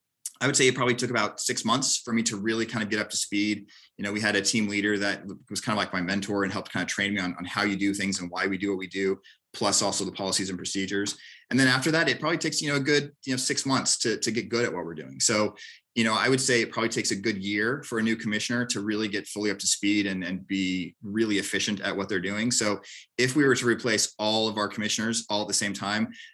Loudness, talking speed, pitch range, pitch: -26 LUFS, 290 wpm, 100-115 Hz, 105 Hz